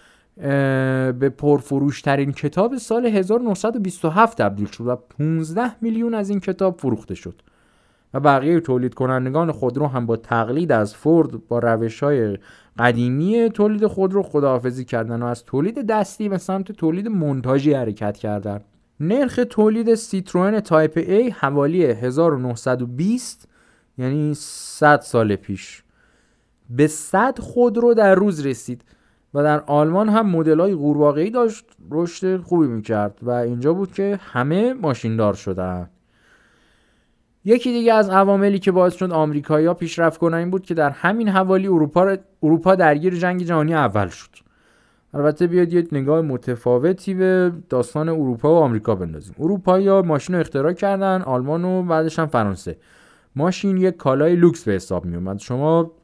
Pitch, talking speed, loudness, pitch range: 155 Hz, 140 wpm, -19 LUFS, 125-190 Hz